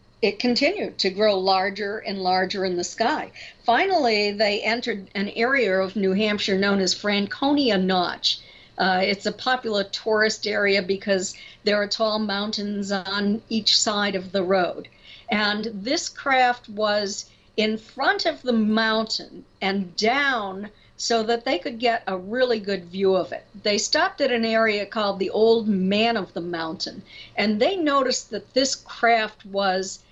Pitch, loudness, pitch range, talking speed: 210 Hz, -23 LUFS, 195-230 Hz, 160 wpm